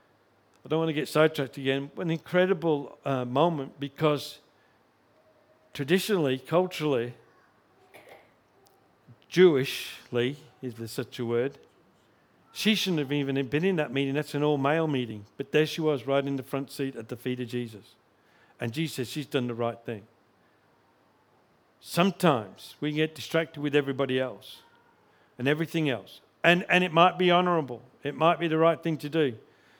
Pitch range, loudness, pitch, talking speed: 125-160 Hz, -27 LUFS, 145 Hz, 160 wpm